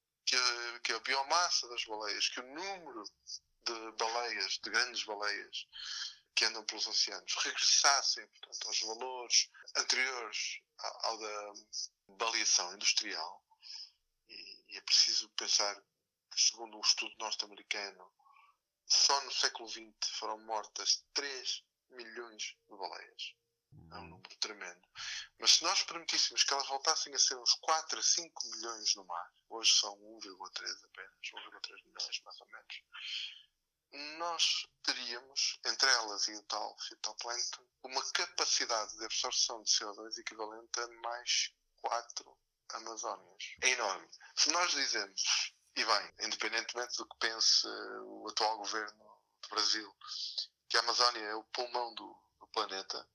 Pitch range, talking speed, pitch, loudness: 110-140 Hz, 135 wpm, 120 Hz, -33 LUFS